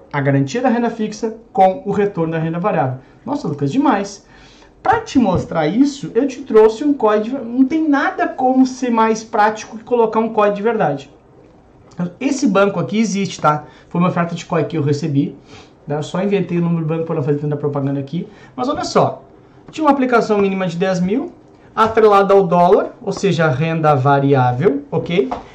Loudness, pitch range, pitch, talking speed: -16 LUFS, 155-230 Hz, 195 Hz, 190 wpm